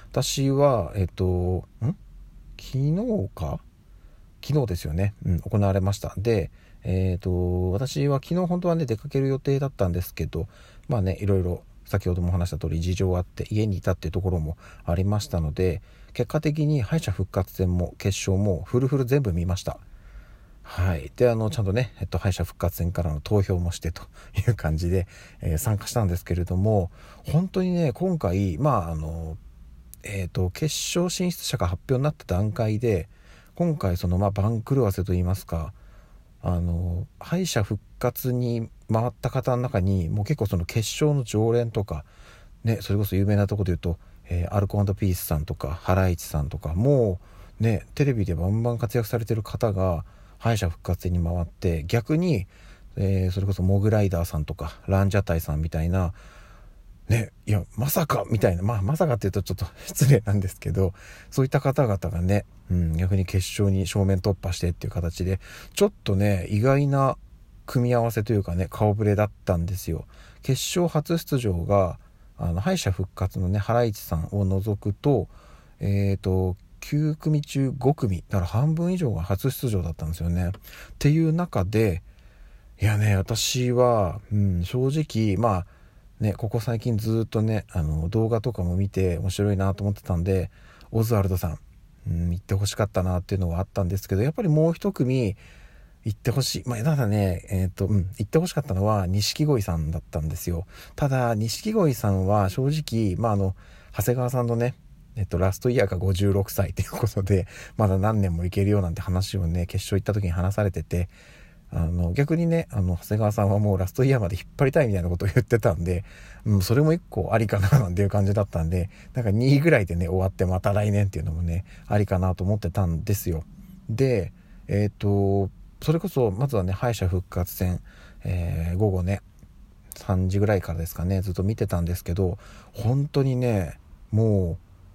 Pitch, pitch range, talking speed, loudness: 100 Hz, 90-120 Hz, 355 characters per minute, -25 LUFS